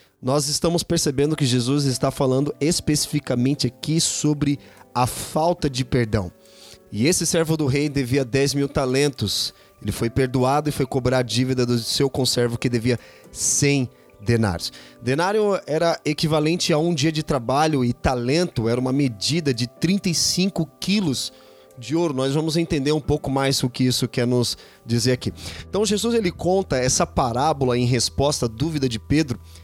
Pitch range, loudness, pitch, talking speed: 125-155 Hz, -21 LUFS, 135 Hz, 165 wpm